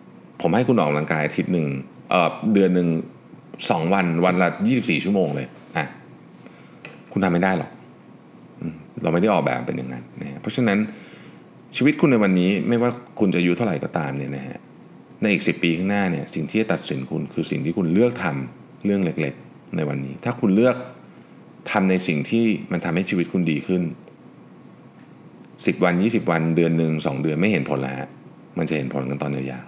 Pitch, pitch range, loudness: 85 Hz, 70-95 Hz, -22 LUFS